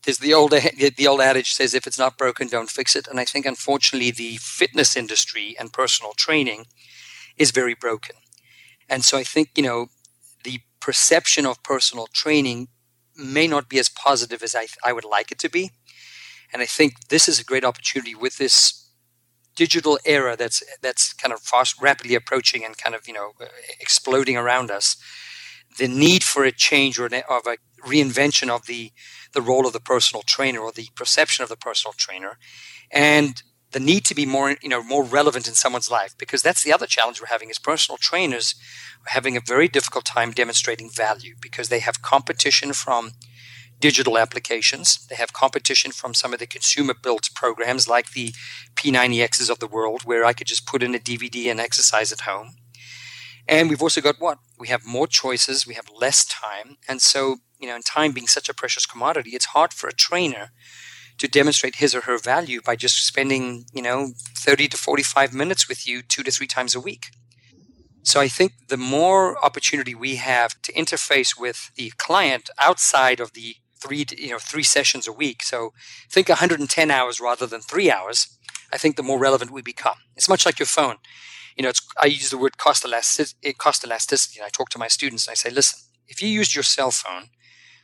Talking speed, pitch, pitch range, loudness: 195 wpm, 130 Hz, 120-140 Hz, -19 LUFS